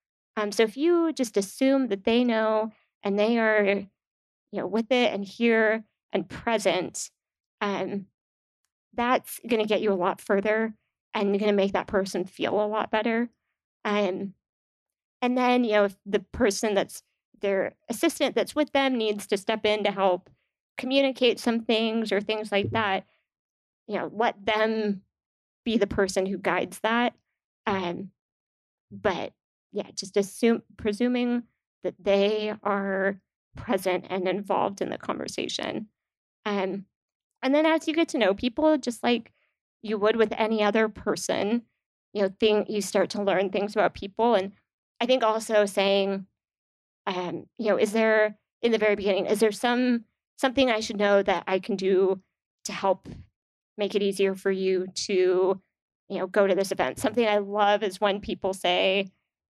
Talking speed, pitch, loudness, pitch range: 165 wpm, 210 Hz, -26 LUFS, 195-225 Hz